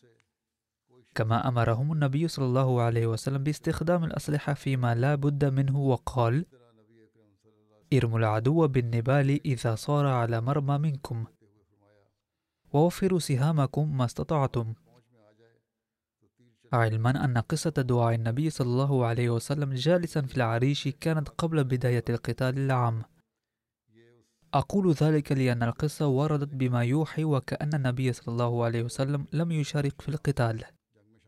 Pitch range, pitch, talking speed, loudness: 115-145 Hz, 130 Hz, 115 wpm, -27 LUFS